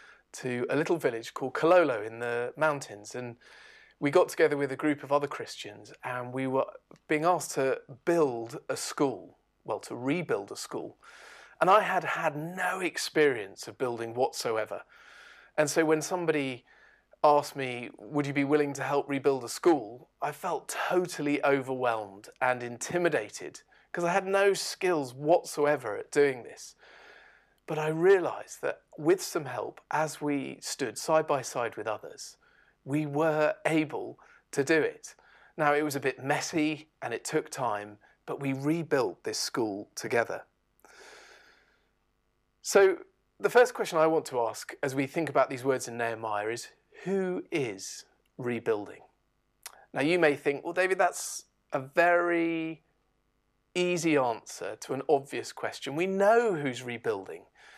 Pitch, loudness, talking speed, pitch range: 150 Hz, -29 LUFS, 155 wpm, 135-175 Hz